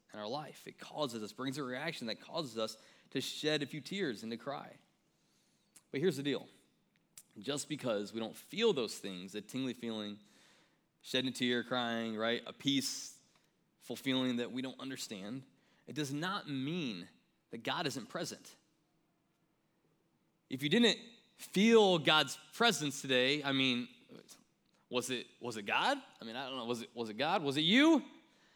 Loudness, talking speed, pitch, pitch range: -35 LUFS, 170 wpm, 135 Hz, 120-165 Hz